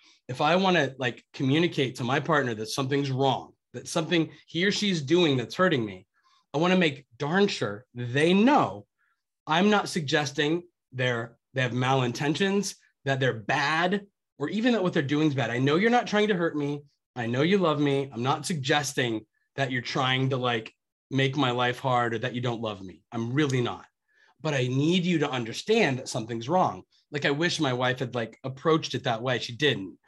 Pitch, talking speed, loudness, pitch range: 140 Hz, 205 wpm, -26 LUFS, 125-170 Hz